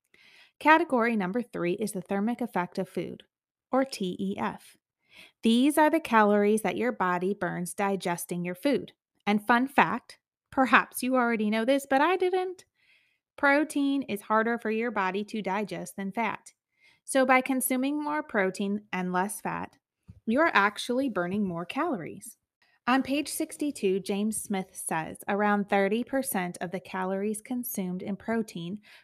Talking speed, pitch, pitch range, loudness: 145 wpm, 215 Hz, 195-265 Hz, -28 LUFS